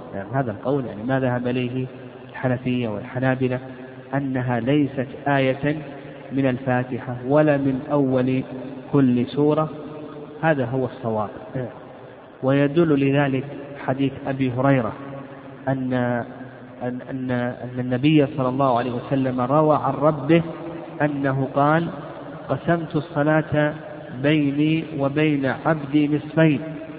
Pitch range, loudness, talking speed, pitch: 130-150 Hz, -22 LUFS, 100 wpm, 135 Hz